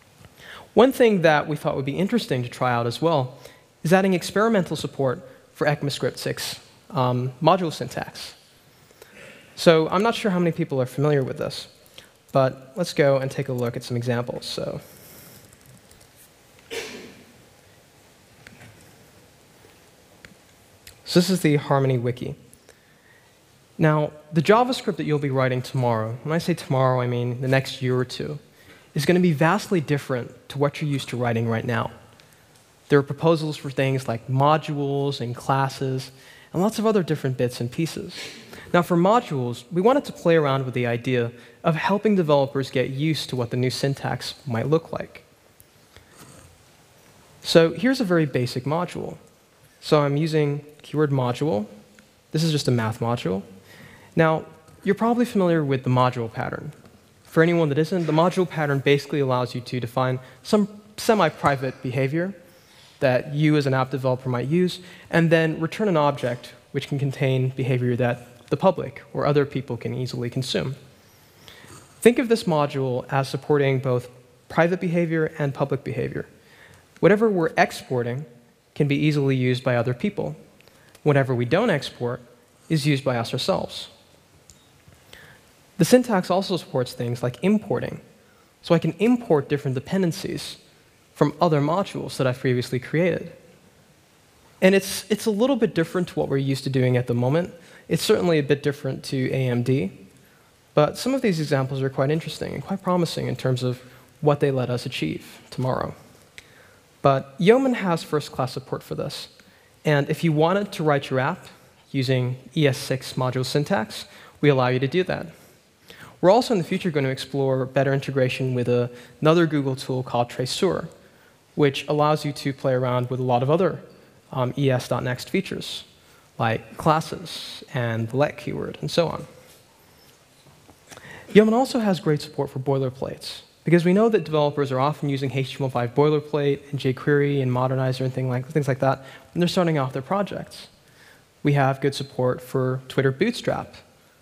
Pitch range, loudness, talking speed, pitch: 130-165 Hz, -23 LUFS, 165 wpm, 140 Hz